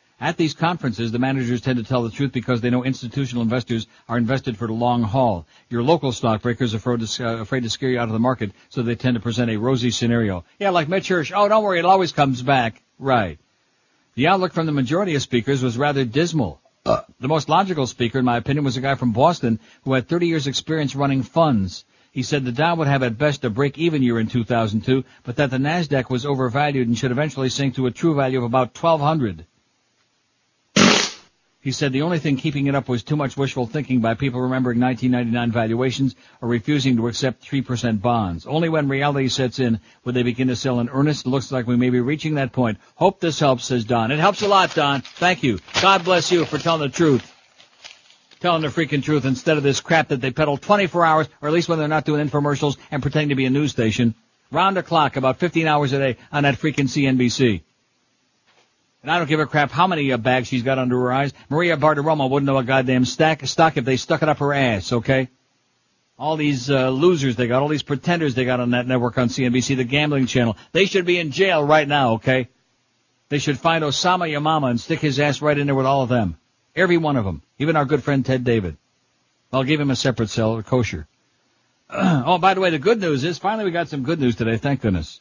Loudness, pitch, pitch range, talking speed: -20 LUFS, 135 Hz, 125-150 Hz, 225 wpm